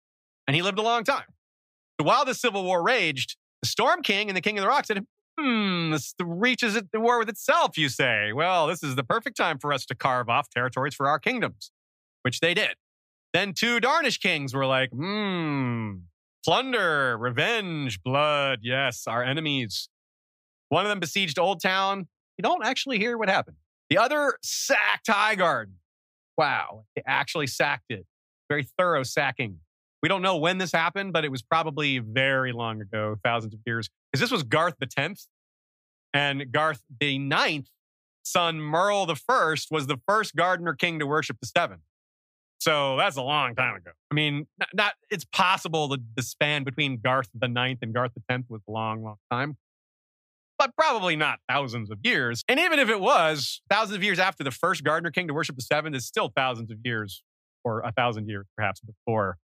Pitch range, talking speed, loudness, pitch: 120-185 Hz, 190 wpm, -25 LUFS, 145 Hz